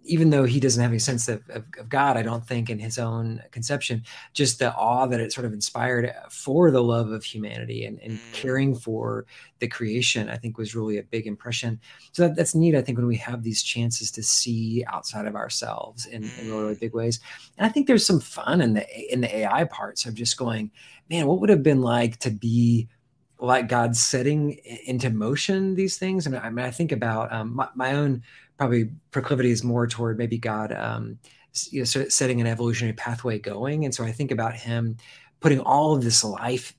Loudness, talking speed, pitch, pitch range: -24 LUFS, 220 wpm, 120 Hz, 115-135 Hz